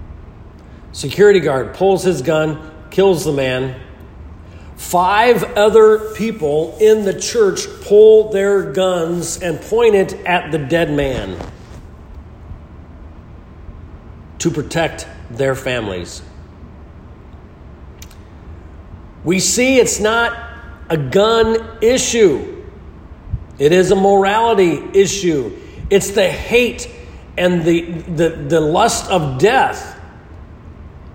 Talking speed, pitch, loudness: 95 wpm, 155 Hz, -14 LUFS